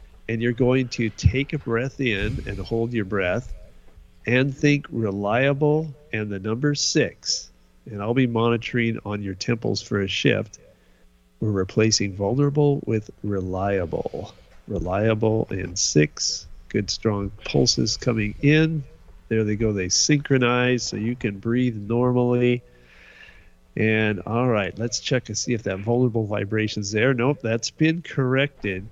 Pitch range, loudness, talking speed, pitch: 100-125 Hz, -23 LUFS, 140 wpm, 110 Hz